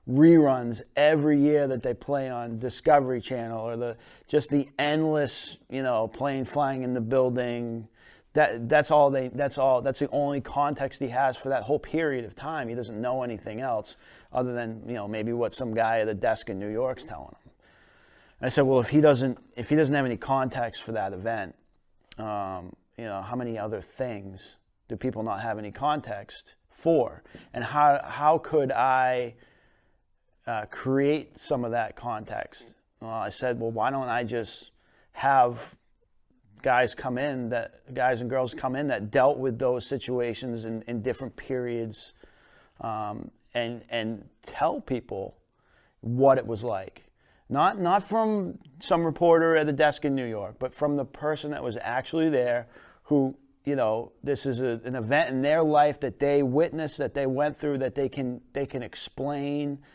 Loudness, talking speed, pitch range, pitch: -27 LUFS, 180 wpm, 115-145 Hz, 130 Hz